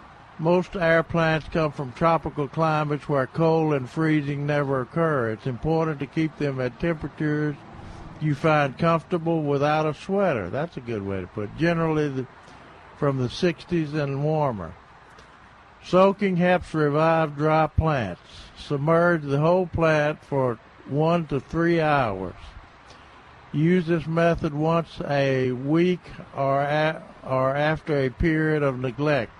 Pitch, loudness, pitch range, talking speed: 150 Hz, -24 LUFS, 135-165 Hz, 140 wpm